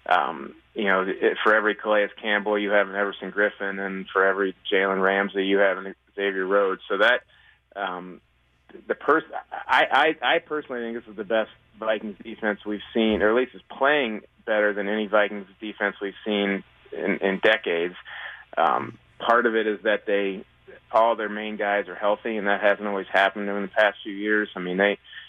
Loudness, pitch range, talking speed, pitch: -24 LUFS, 95-105 Hz, 200 wpm, 100 Hz